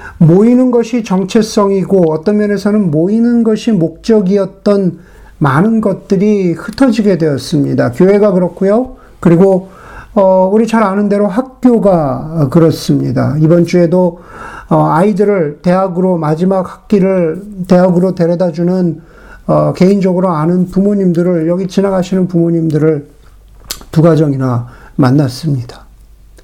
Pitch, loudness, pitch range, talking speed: 185 Hz, -11 LUFS, 160-200 Hz, 295 characters per minute